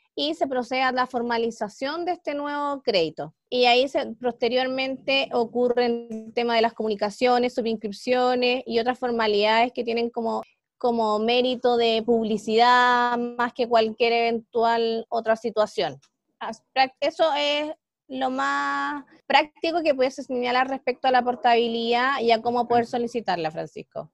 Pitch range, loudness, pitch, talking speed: 230-265 Hz, -23 LUFS, 245 Hz, 135 wpm